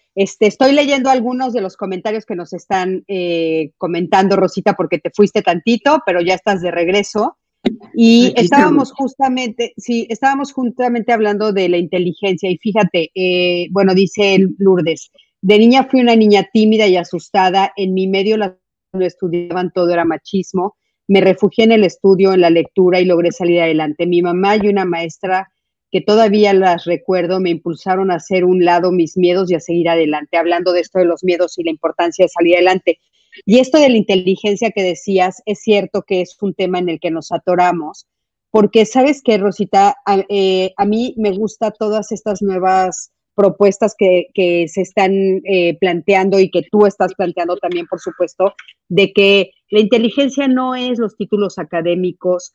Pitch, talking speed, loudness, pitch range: 190 Hz, 180 wpm, -14 LUFS, 180-210 Hz